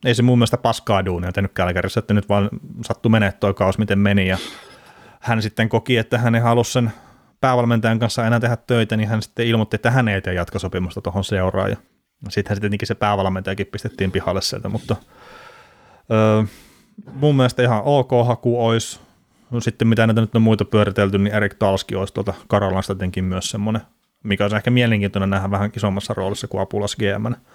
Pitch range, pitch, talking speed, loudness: 100-115 Hz, 110 Hz, 180 wpm, -19 LUFS